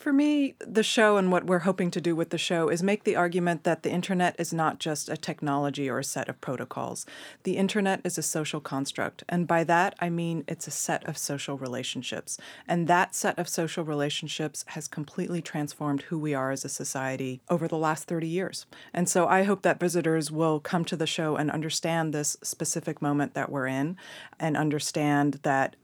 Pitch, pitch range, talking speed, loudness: 165 Hz, 145-175 Hz, 205 wpm, -28 LUFS